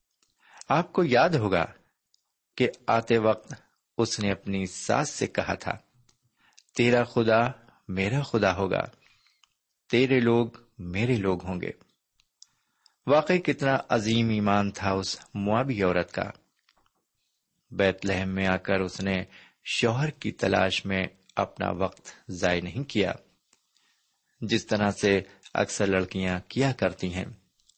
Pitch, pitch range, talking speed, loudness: 100 Hz, 95-120 Hz, 125 wpm, -27 LUFS